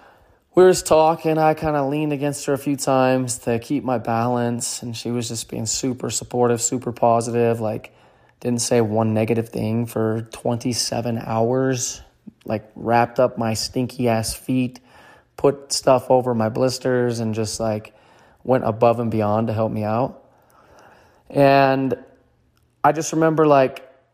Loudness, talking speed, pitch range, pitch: -20 LUFS, 155 wpm, 115-135 Hz, 120 Hz